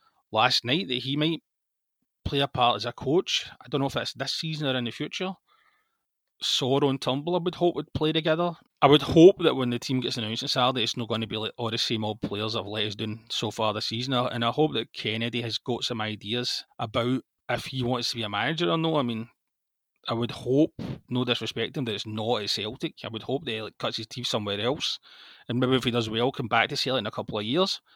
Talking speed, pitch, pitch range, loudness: 255 wpm, 125 Hz, 115-145 Hz, -26 LUFS